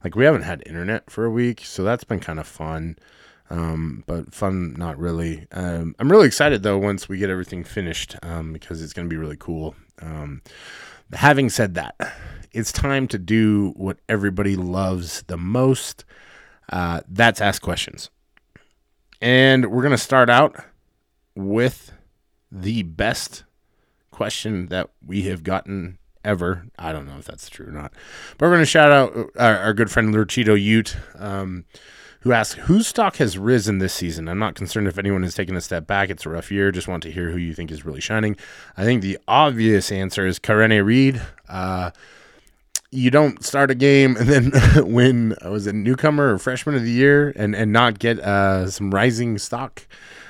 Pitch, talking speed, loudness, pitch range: 100 Hz, 185 wpm, -19 LUFS, 90-120 Hz